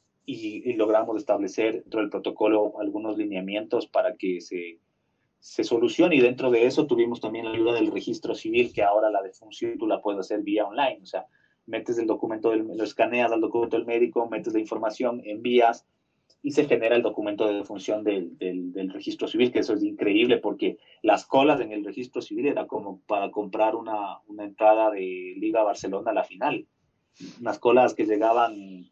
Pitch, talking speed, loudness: 115 Hz, 190 wpm, -25 LUFS